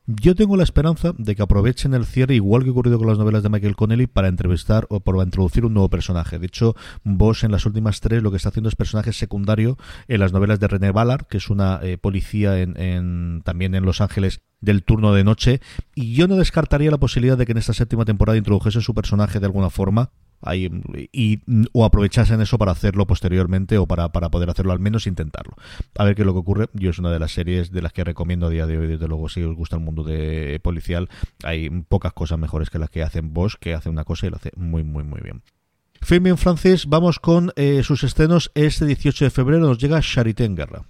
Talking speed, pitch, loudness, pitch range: 240 wpm, 100 Hz, -19 LUFS, 90-120 Hz